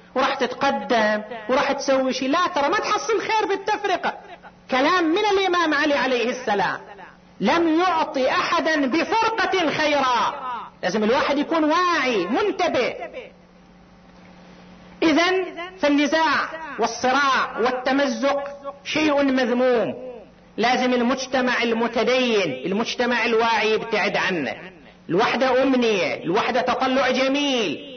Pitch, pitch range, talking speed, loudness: 275 Hz, 250-335 Hz, 95 wpm, -21 LUFS